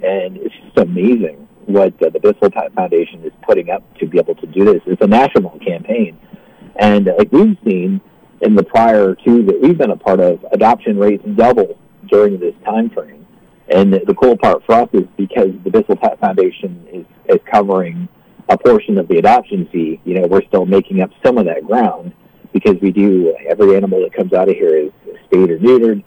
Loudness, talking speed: -13 LUFS, 205 wpm